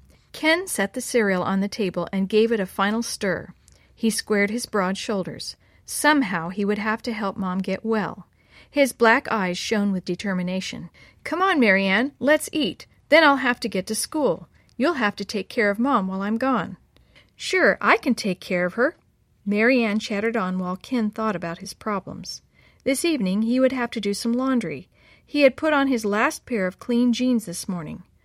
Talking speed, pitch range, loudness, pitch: 195 wpm, 195-255 Hz, -22 LUFS, 220 Hz